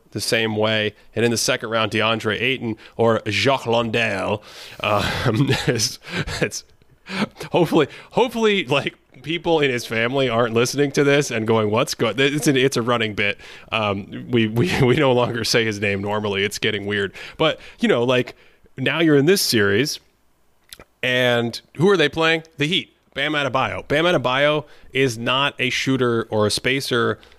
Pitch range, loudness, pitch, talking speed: 110-140 Hz, -20 LUFS, 120 Hz, 165 wpm